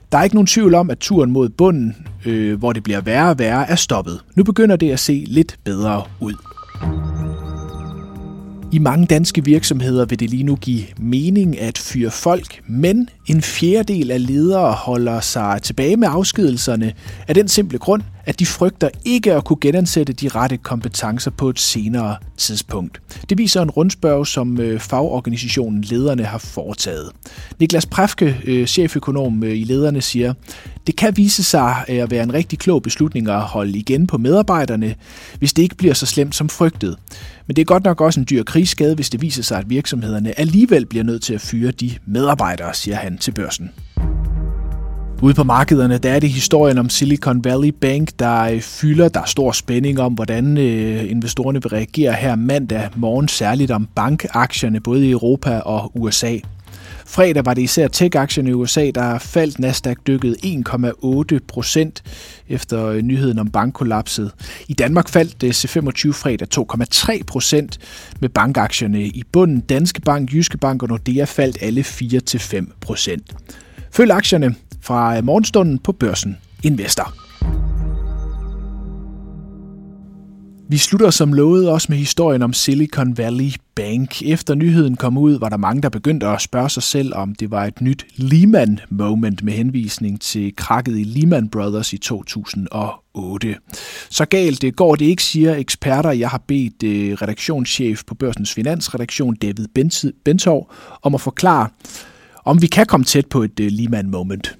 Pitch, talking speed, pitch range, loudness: 125 Hz, 160 wpm, 110-155 Hz, -16 LUFS